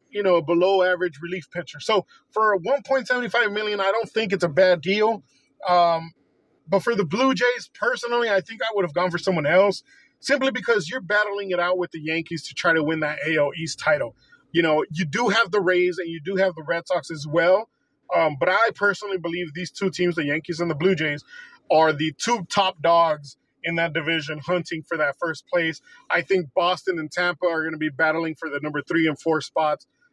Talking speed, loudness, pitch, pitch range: 220 wpm, -23 LUFS, 180 Hz, 165-205 Hz